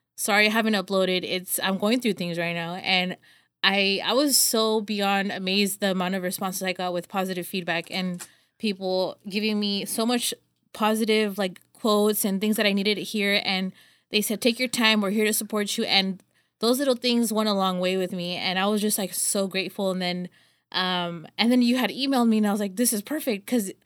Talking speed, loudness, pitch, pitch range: 220 wpm, -24 LUFS, 200 Hz, 185-220 Hz